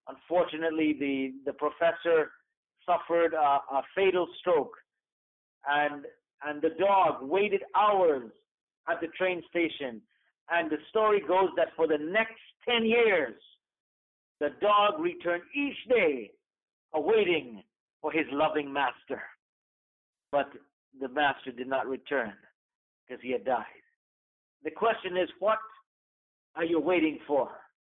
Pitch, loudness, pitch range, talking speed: 170 Hz, -29 LUFS, 145-220 Hz, 120 wpm